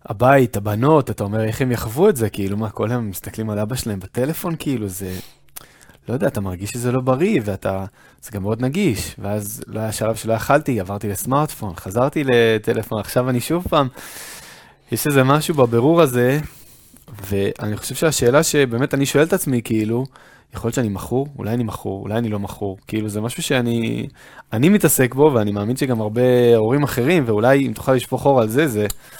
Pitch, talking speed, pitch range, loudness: 120 Hz, 190 wpm, 105-135 Hz, -19 LUFS